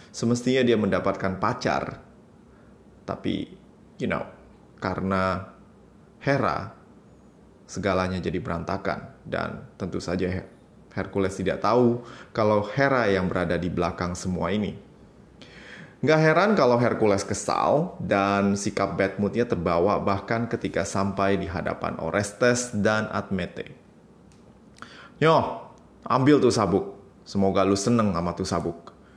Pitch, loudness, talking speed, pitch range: 100 Hz, -25 LUFS, 110 wpm, 95-115 Hz